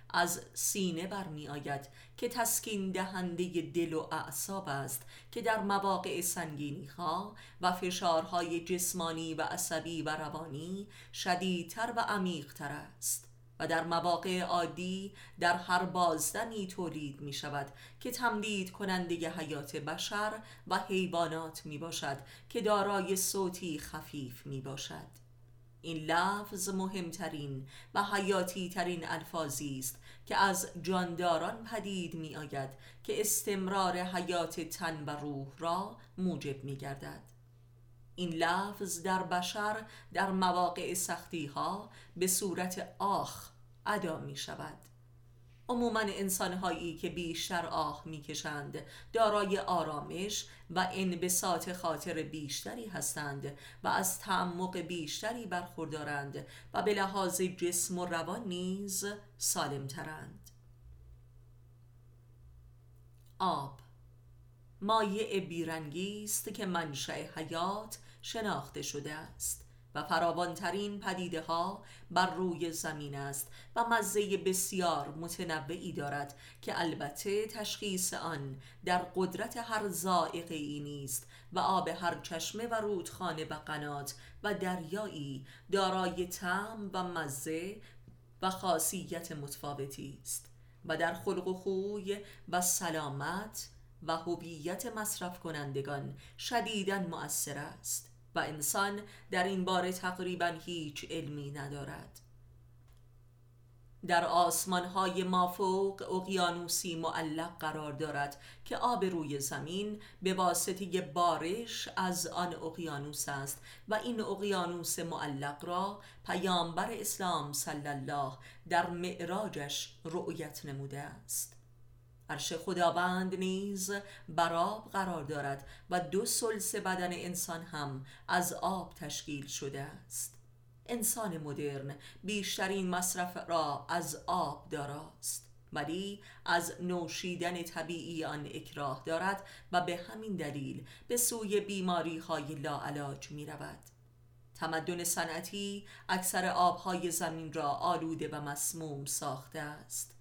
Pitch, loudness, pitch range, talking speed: 170 Hz, -36 LUFS, 145-185 Hz, 110 wpm